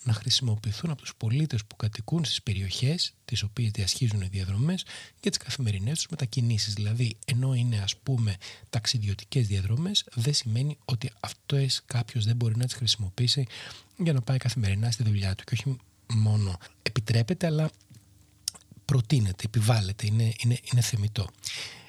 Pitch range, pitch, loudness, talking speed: 105-130 Hz, 115 Hz, -28 LUFS, 150 wpm